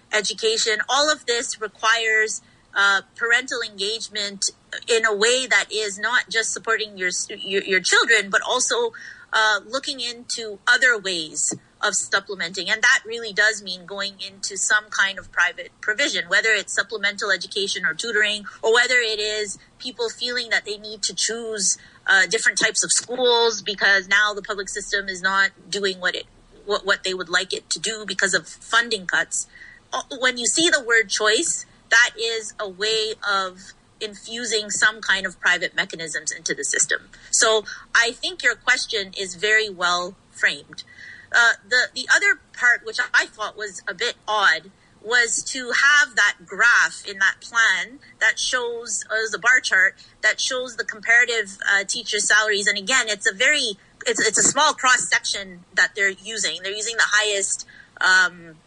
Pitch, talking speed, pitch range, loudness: 220 Hz, 170 wpm, 200-245 Hz, -20 LUFS